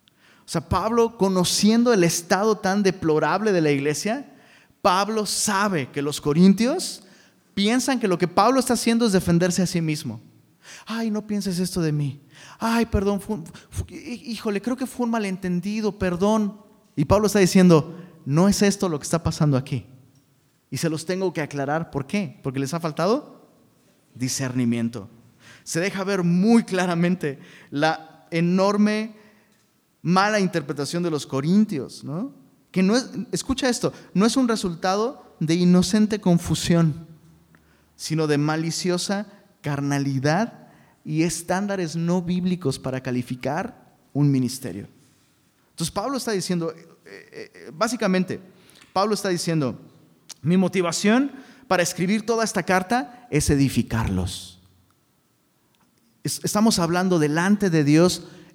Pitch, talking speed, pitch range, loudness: 180 Hz, 130 wpm, 150-210 Hz, -22 LUFS